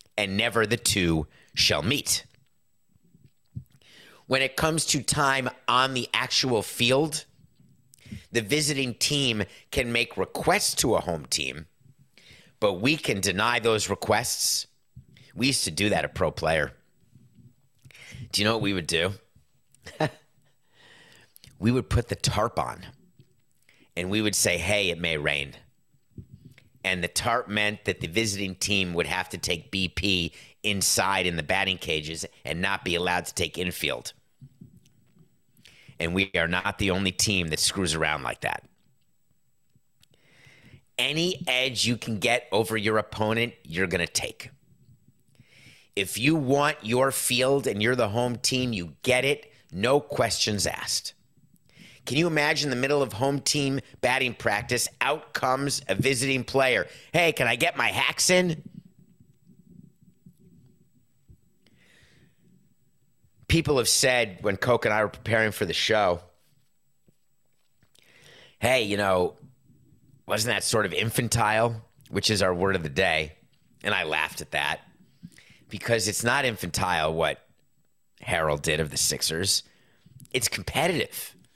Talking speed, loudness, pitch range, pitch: 140 wpm, -25 LUFS, 95-130 Hz, 115 Hz